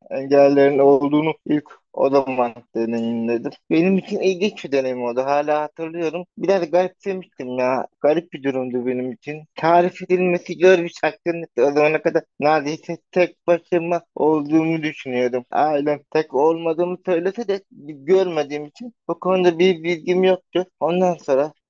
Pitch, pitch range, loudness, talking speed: 160 Hz, 145-180 Hz, -20 LUFS, 135 wpm